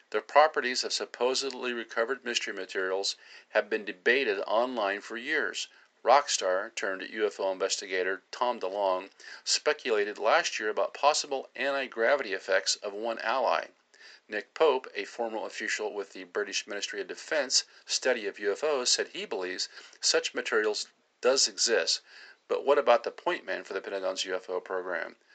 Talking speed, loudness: 145 wpm, -29 LUFS